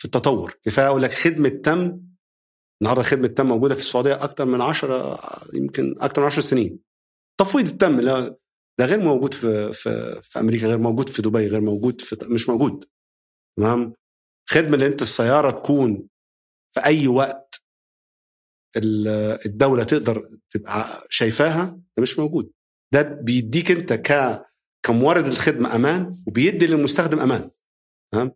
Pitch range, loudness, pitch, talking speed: 110-145 Hz, -20 LUFS, 130 Hz, 140 wpm